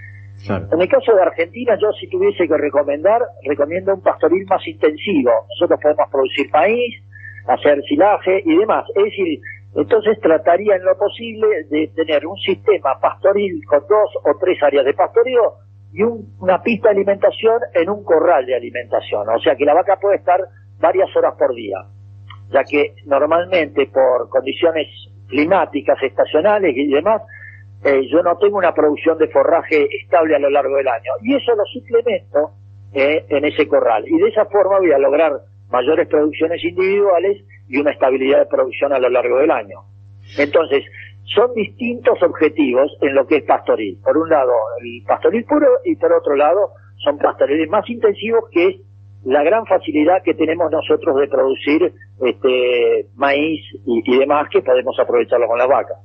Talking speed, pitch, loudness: 170 wpm, 170 Hz, -16 LUFS